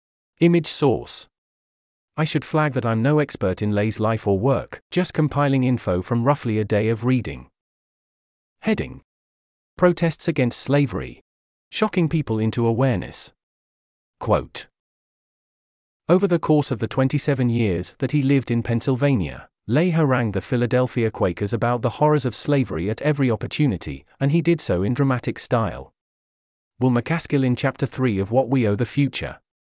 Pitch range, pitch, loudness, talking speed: 95-145 Hz, 125 Hz, -21 LUFS, 150 wpm